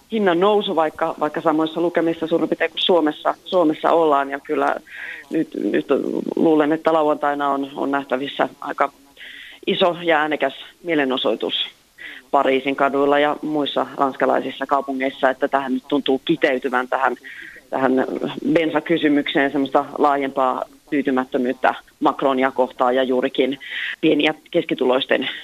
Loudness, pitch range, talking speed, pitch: -20 LUFS, 135-160 Hz, 120 wpm, 145 Hz